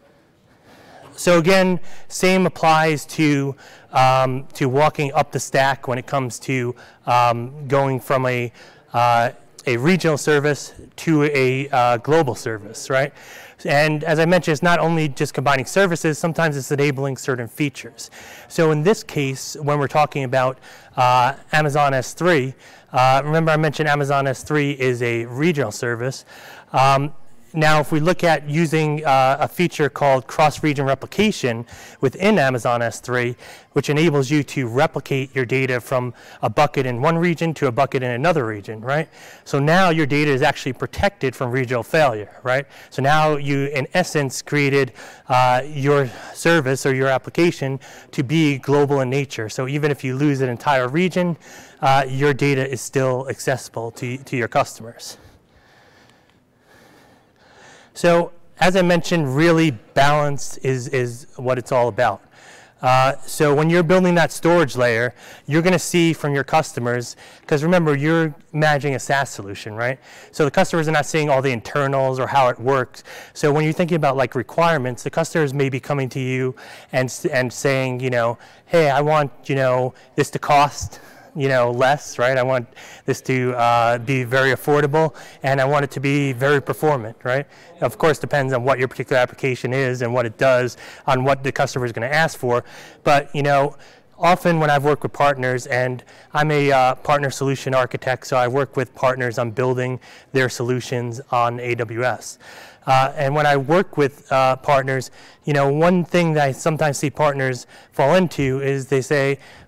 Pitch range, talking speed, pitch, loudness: 130-155 Hz, 170 wpm, 140 Hz, -19 LUFS